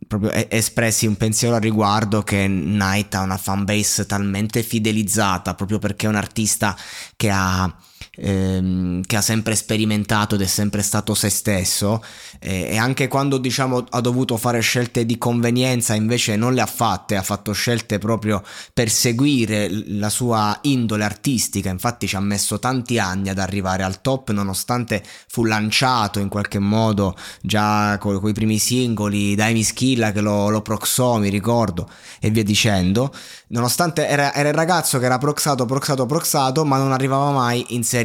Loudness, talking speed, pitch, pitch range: -19 LUFS, 165 wpm, 110 Hz, 100-120 Hz